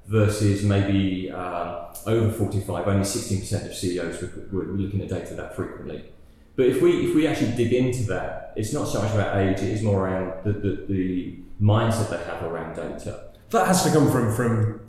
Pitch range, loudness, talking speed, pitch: 90-110 Hz, -24 LUFS, 195 wpm, 100 Hz